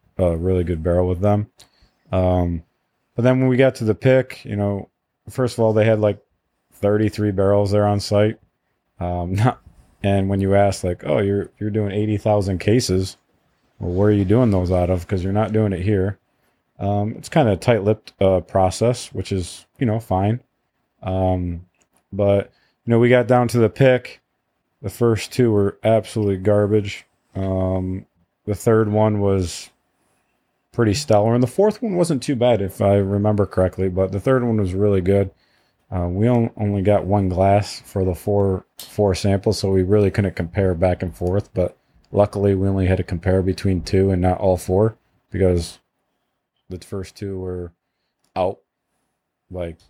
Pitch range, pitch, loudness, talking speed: 95-110 Hz, 100 Hz, -19 LUFS, 180 wpm